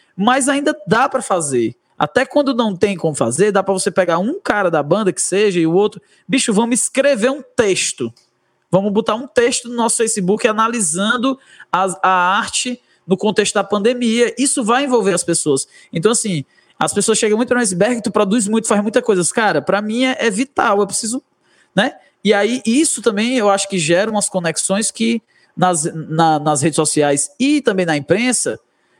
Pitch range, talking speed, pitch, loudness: 185-245 Hz, 190 wpm, 210 Hz, -16 LUFS